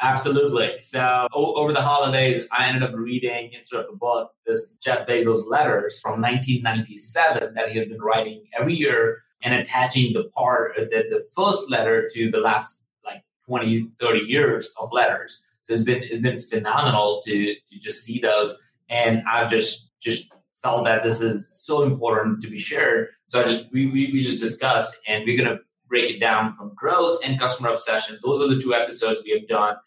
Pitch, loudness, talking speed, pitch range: 120 Hz, -22 LUFS, 190 wpm, 115-135 Hz